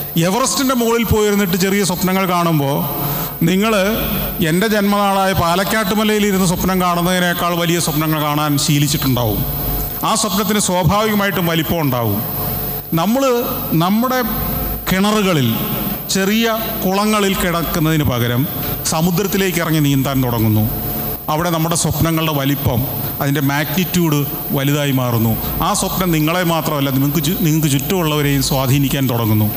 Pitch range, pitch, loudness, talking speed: 145-195 Hz, 165 Hz, -16 LUFS, 100 wpm